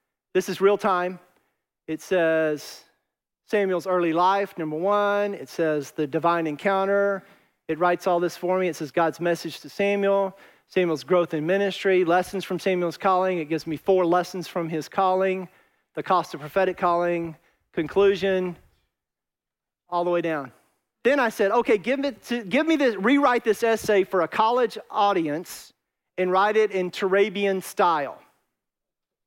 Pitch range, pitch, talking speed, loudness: 170-200 Hz, 185 Hz, 155 wpm, -23 LUFS